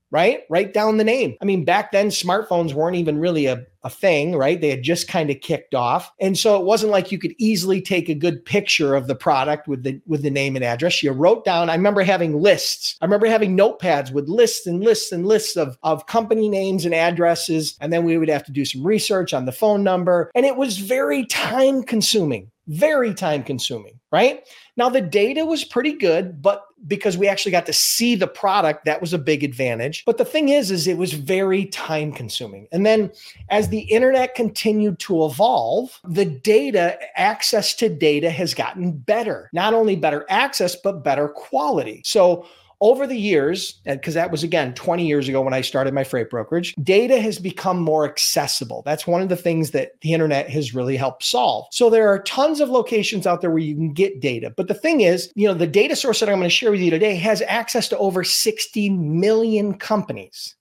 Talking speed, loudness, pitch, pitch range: 215 wpm, -19 LUFS, 185 Hz, 155-215 Hz